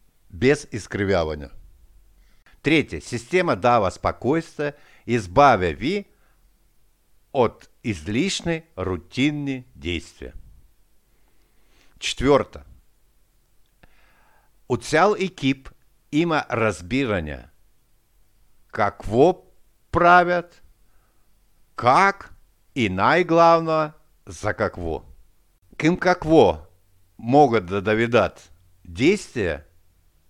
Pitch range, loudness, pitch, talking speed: 90-150 Hz, -21 LUFS, 115 Hz, 65 wpm